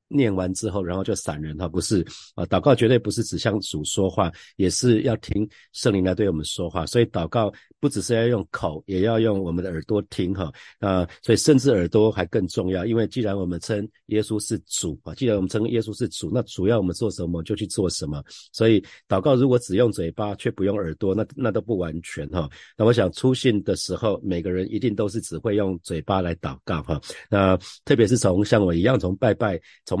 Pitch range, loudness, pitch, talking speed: 90-115 Hz, -23 LUFS, 100 Hz, 325 characters per minute